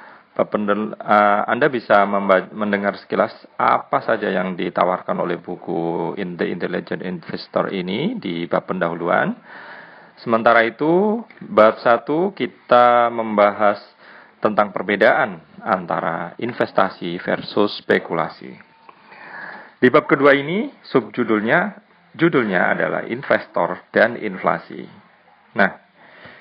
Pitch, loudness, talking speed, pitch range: 110 Hz, -19 LUFS, 100 wpm, 100-145 Hz